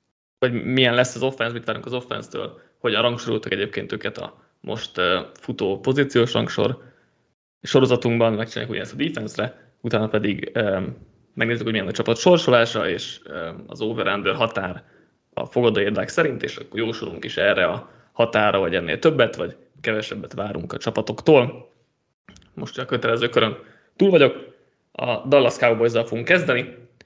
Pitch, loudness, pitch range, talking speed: 120 Hz, -21 LUFS, 115-125 Hz, 150 wpm